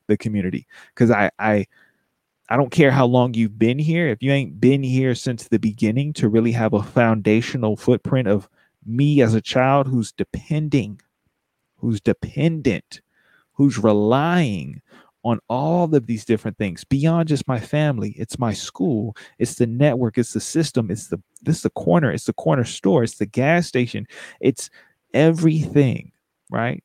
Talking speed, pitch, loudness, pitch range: 165 wpm, 125 Hz, -20 LUFS, 110-140 Hz